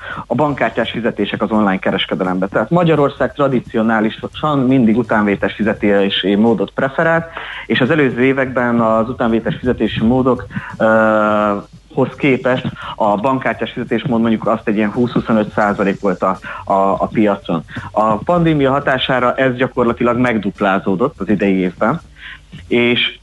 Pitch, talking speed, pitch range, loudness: 115 Hz, 125 wpm, 105-130 Hz, -15 LUFS